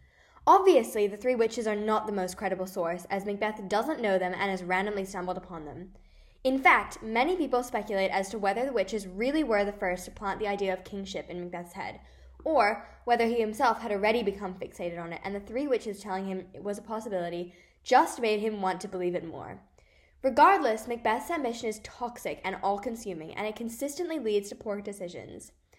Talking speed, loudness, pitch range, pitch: 200 wpm, -29 LUFS, 185-225 Hz, 205 Hz